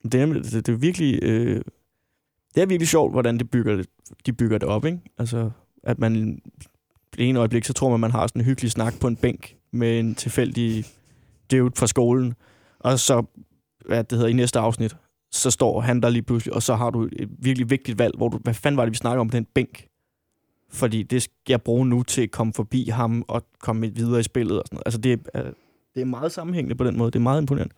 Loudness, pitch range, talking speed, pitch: -23 LUFS, 115-125 Hz, 245 wpm, 120 Hz